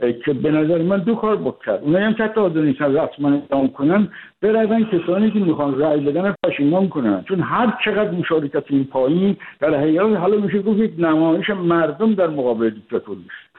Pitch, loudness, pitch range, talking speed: 170 Hz, -18 LUFS, 145-210 Hz, 195 wpm